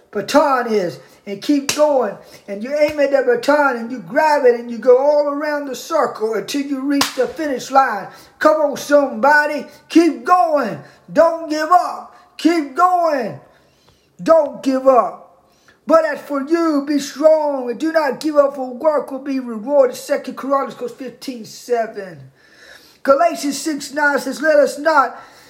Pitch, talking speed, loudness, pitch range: 280 Hz, 160 wpm, -17 LUFS, 255-305 Hz